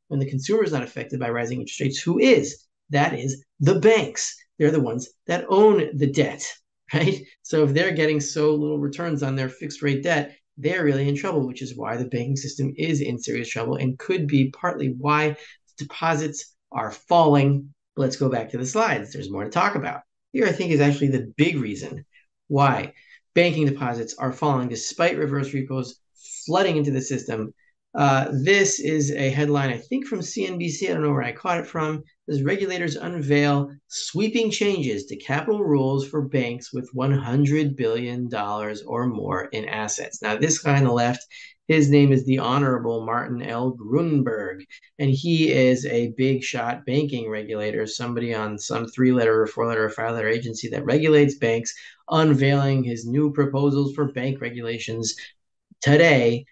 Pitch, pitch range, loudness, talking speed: 140 Hz, 125-150 Hz, -23 LUFS, 175 wpm